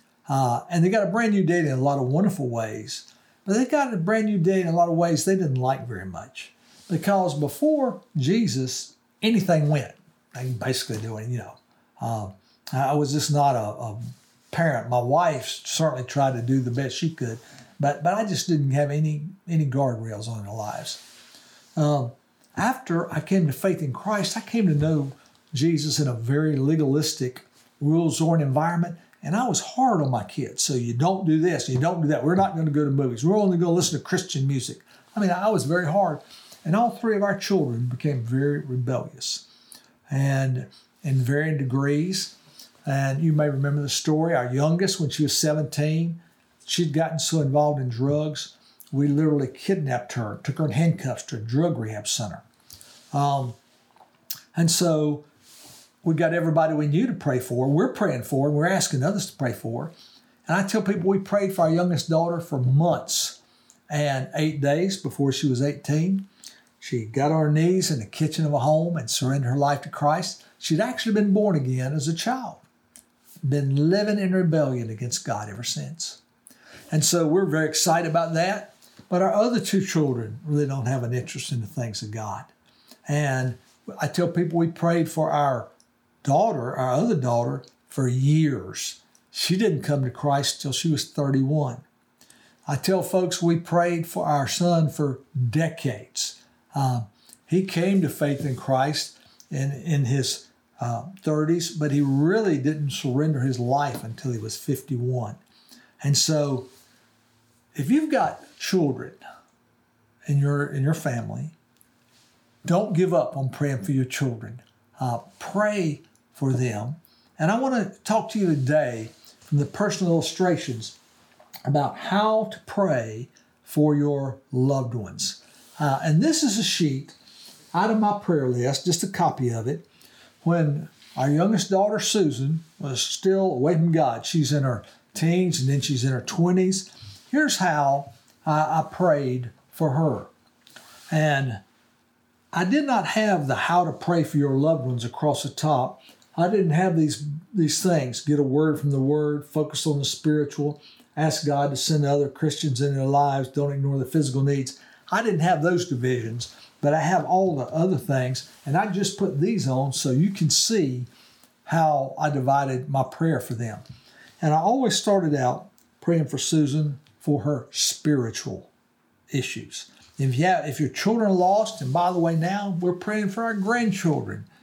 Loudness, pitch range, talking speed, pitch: -24 LUFS, 135-175 Hz, 180 wpm, 150 Hz